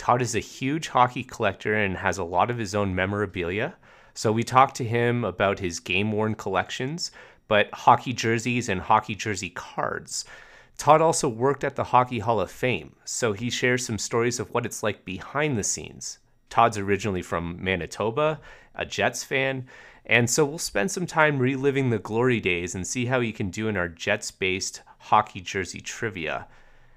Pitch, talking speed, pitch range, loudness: 115 Hz, 180 wpm, 100-130 Hz, -25 LUFS